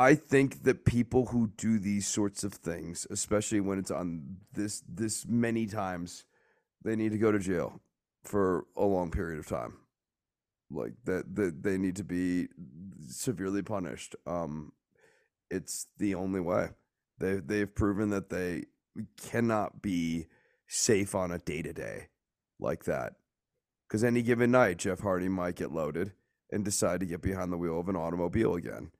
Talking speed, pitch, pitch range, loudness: 165 wpm, 100 Hz, 90-110 Hz, -32 LUFS